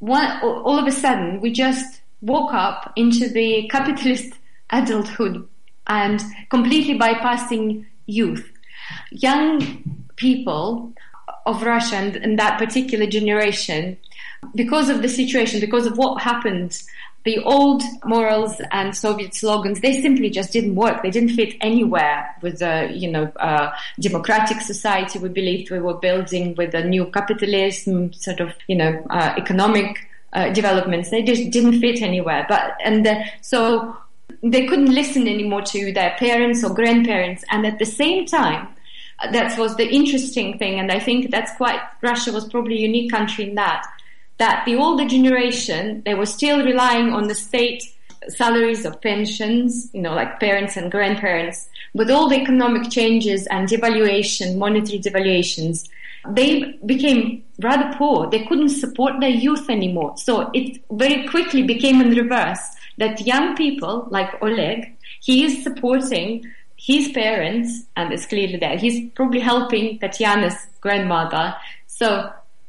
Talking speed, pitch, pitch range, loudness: 150 wpm, 225 Hz, 200-250 Hz, -19 LUFS